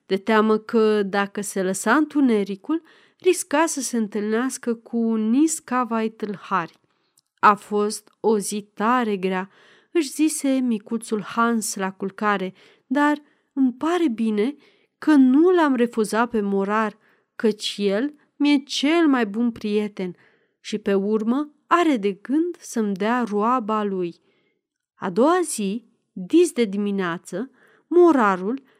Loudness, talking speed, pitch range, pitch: -22 LUFS, 125 wpm, 210-285 Hz, 230 Hz